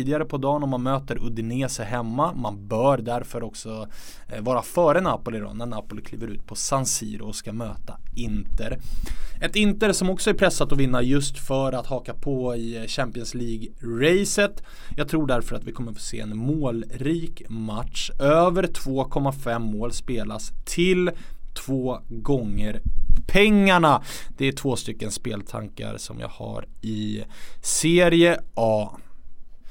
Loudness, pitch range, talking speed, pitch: -24 LUFS, 110-145 Hz, 145 wpm, 120 Hz